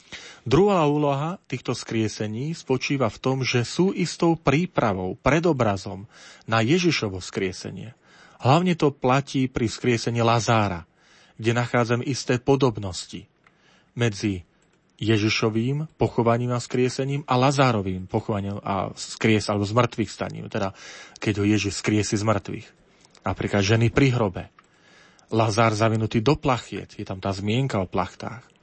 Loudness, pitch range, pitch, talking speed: -23 LUFS, 105-135 Hz, 115 Hz, 125 wpm